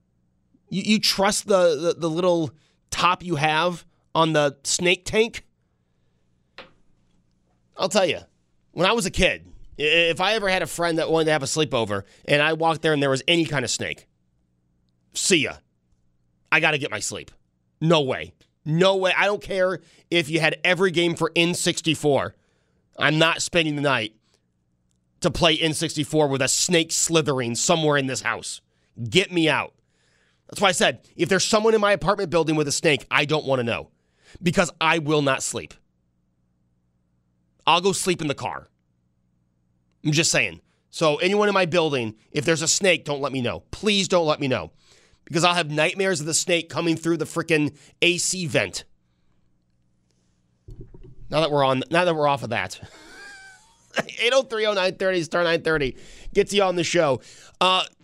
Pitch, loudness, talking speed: 150 Hz, -22 LUFS, 175 wpm